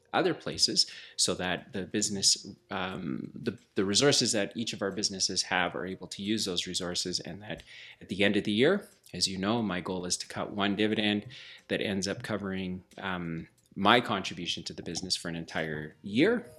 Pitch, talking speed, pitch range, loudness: 95 Hz, 195 wpm, 90-105 Hz, -30 LUFS